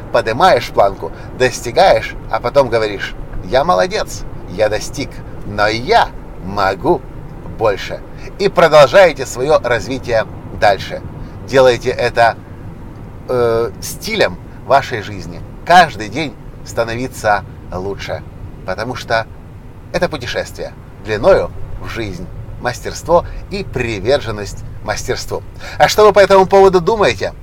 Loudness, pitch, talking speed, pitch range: -14 LUFS, 115 Hz, 105 wpm, 100-130 Hz